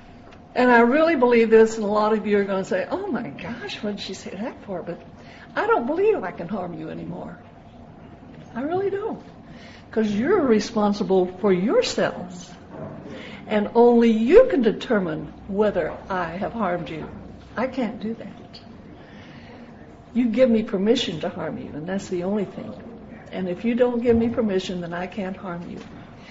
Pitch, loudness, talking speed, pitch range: 220 Hz, -22 LUFS, 180 wpm, 195-245 Hz